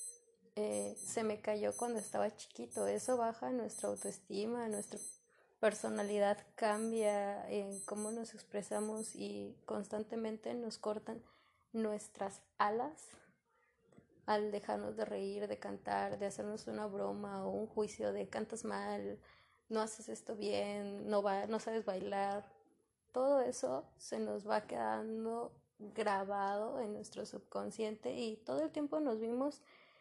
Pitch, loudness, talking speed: 210 Hz, -40 LUFS, 130 wpm